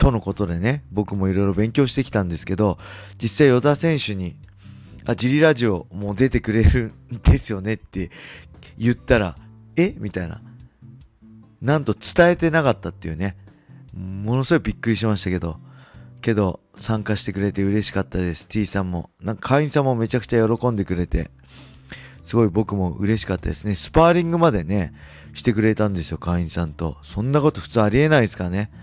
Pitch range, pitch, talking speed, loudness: 95-120 Hz, 105 Hz, 375 characters per minute, -21 LUFS